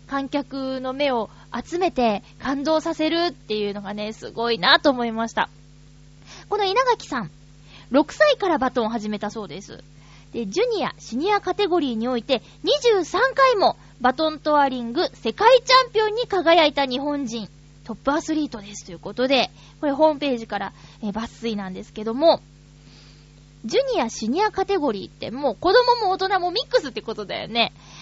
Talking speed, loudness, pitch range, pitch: 350 characters per minute, -22 LUFS, 210-335 Hz, 260 Hz